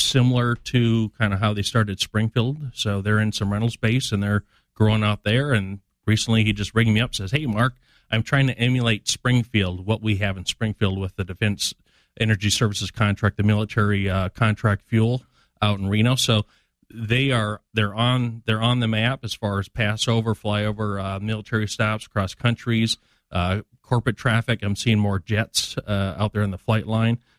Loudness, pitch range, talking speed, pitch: -22 LUFS, 105-115 Hz, 190 wpm, 110 Hz